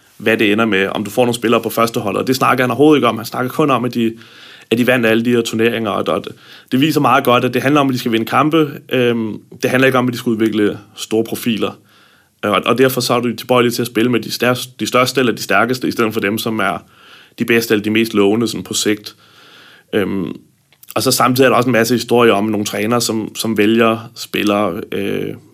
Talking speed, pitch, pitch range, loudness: 255 wpm, 115 Hz, 110-125 Hz, -15 LUFS